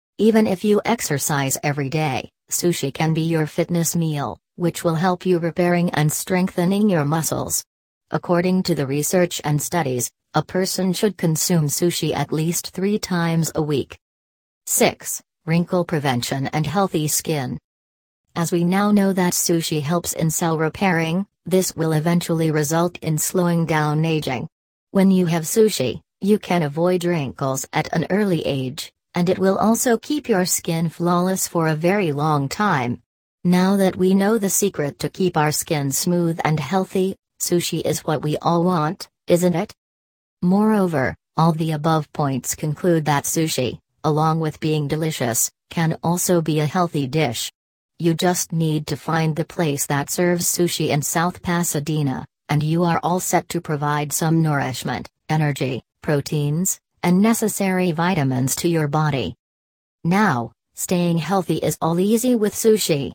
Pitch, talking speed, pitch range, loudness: 165 Hz, 155 wpm, 150-180 Hz, -20 LUFS